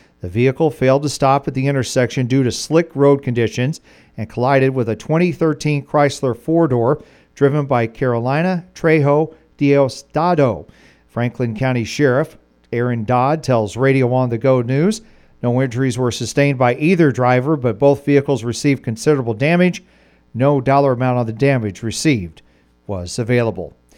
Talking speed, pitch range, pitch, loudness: 150 wpm, 120-145 Hz, 130 Hz, -17 LUFS